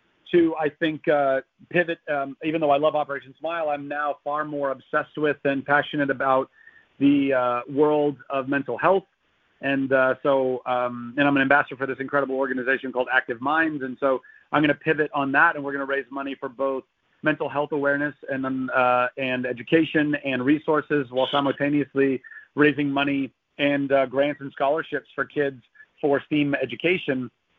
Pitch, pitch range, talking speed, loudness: 140 Hz, 135-150 Hz, 180 wpm, -24 LUFS